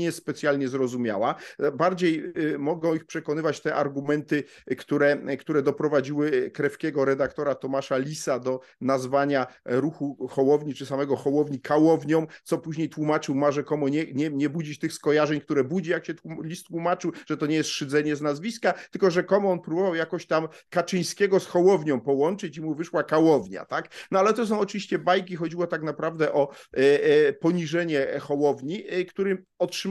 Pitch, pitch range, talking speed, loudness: 155 Hz, 145-175 Hz, 165 wpm, -25 LUFS